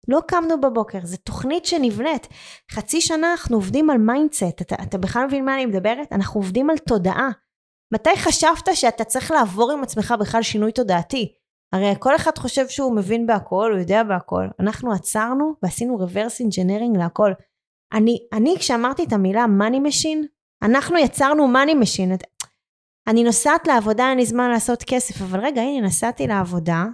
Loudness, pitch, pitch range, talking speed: -19 LUFS, 235 Hz, 205-275 Hz, 165 wpm